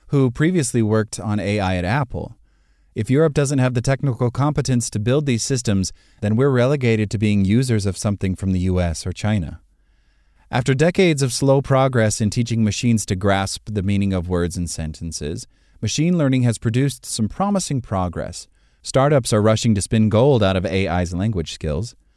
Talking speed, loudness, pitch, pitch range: 175 wpm, -20 LUFS, 110 Hz, 95-130 Hz